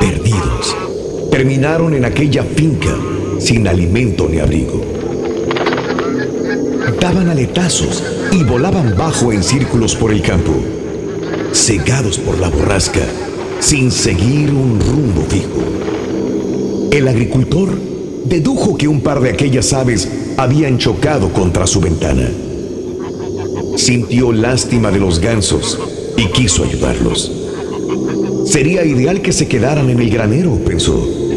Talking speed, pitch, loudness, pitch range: 110 wpm, 120 Hz, -14 LUFS, 95-140 Hz